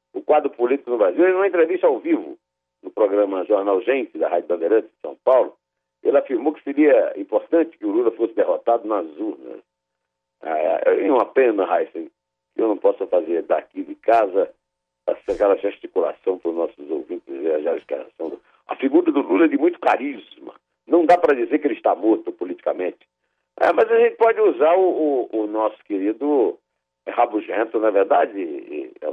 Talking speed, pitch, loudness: 175 wpm, 230 Hz, -20 LUFS